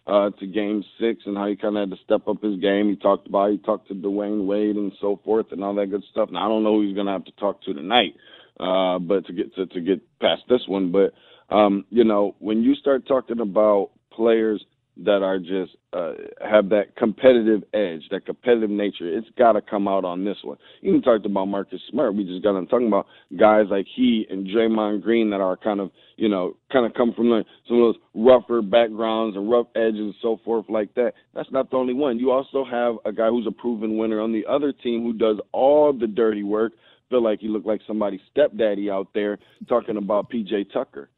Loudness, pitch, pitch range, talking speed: -22 LUFS, 105 Hz, 100-115 Hz, 235 wpm